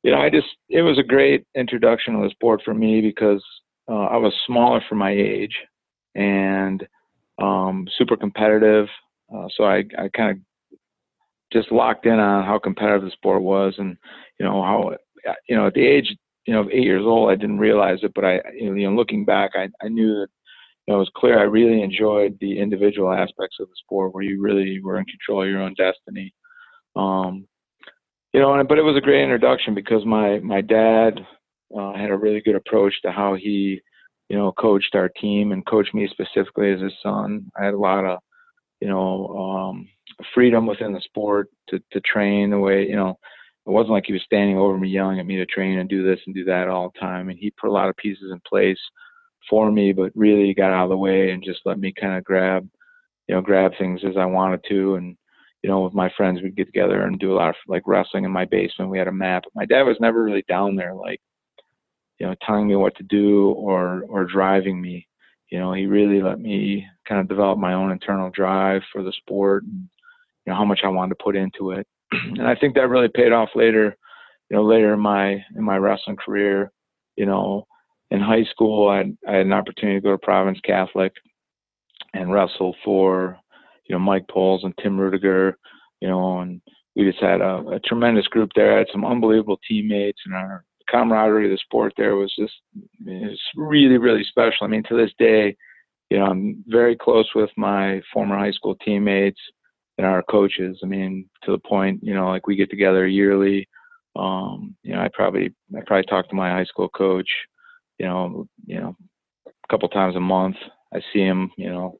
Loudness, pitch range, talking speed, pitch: -20 LUFS, 95-110 Hz, 215 wpm, 100 Hz